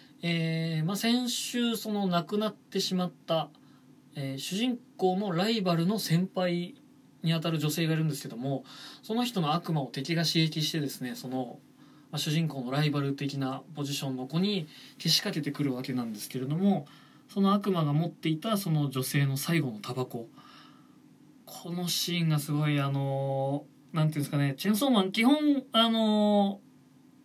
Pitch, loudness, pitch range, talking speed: 160 Hz, -29 LUFS, 140-195 Hz, 340 characters per minute